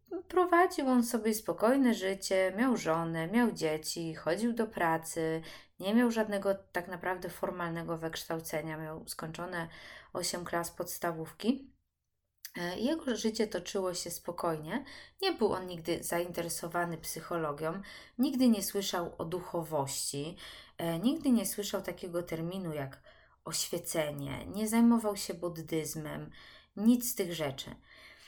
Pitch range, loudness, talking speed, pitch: 165-220 Hz, -33 LUFS, 115 wpm, 175 Hz